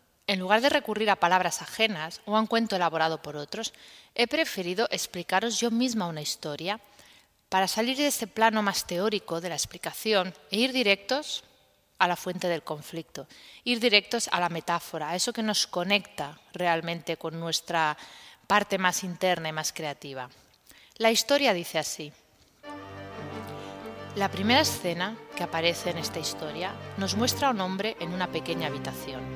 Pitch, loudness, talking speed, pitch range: 180 Hz, -27 LUFS, 160 wpm, 165-220 Hz